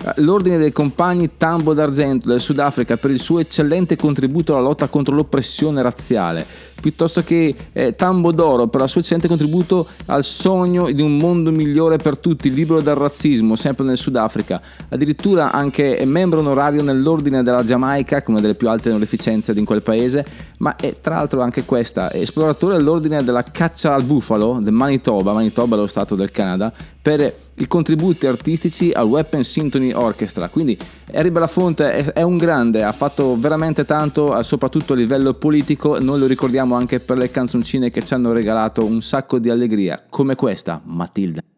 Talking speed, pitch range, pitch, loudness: 175 wpm, 125-160 Hz, 145 Hz, -17 LUFS